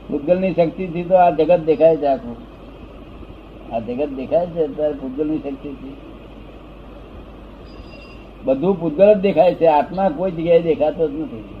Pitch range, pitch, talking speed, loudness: 140-175 Hz, 160 Hz, 140 wpm, -18 LUFS